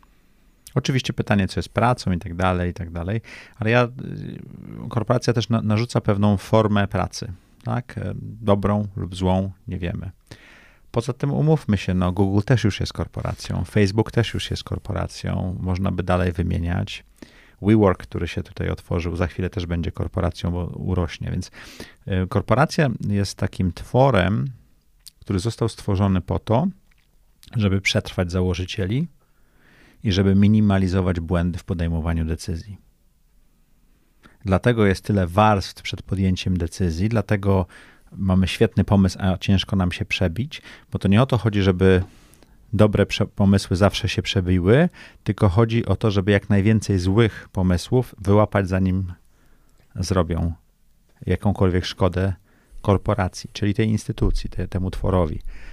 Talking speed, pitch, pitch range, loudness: 135 wpm, 100 Hz, 90-110 Hz, -22 LUFS